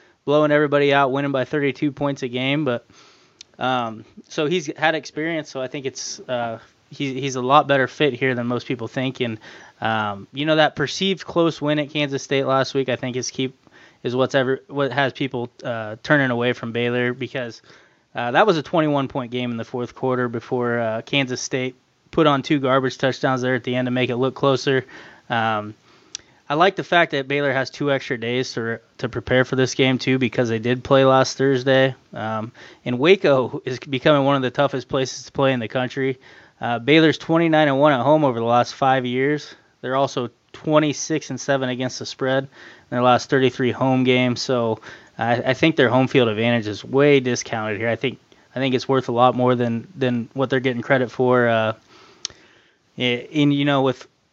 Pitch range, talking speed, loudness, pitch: 125-140 Hz, 210 wpm, -20 LUFS, 130 Hz